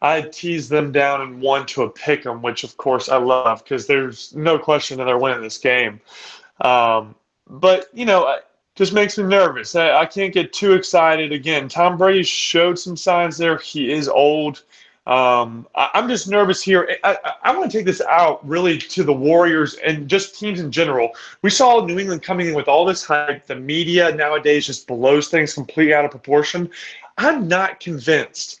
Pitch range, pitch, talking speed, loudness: 140-185 Hz, 160 Hz, 200 wpm, -17 LUFS